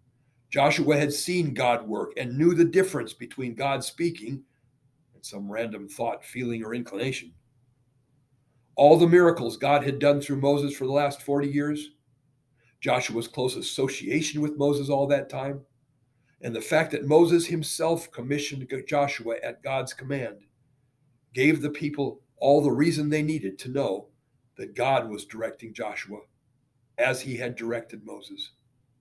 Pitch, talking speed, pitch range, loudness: 135 Hz, 145 wpm, 125-145 Hz, -25 LUFS